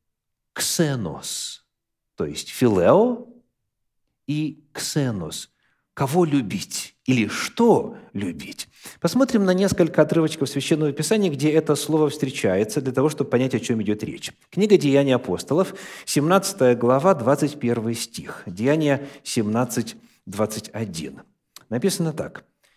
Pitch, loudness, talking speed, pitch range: 145 Hz, -22 LUFS, 105 wpm, 125-165 Hz